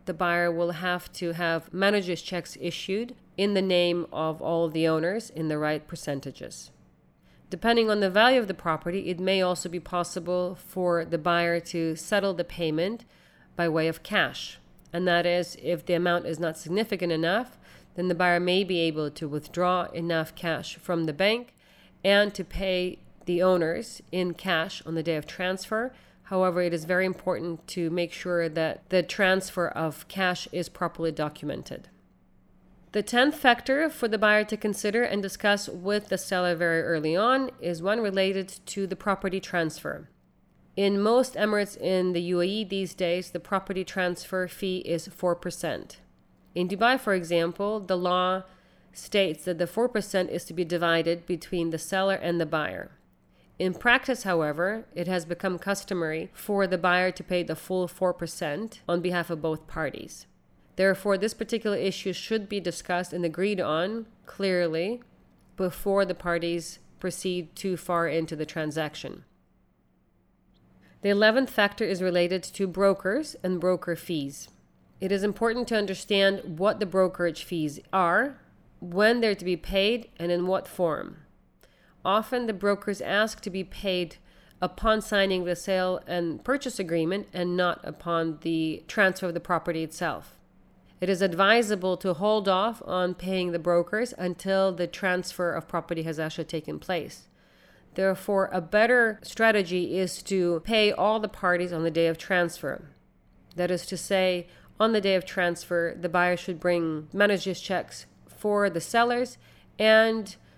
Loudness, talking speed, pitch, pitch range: -27 LUFS, 160 wpm, 180 Hz, 170-200 Hz